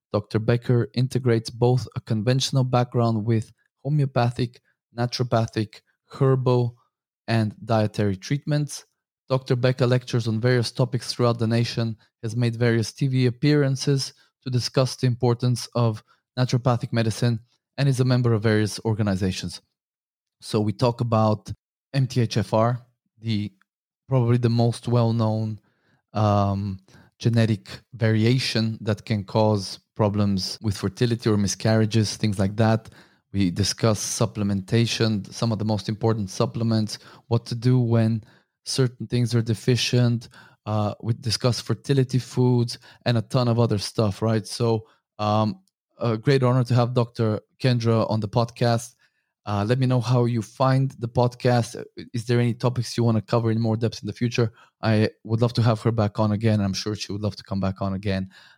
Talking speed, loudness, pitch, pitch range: 155 wpm, -23 LUFS, 115 Hz, 110-125 Hz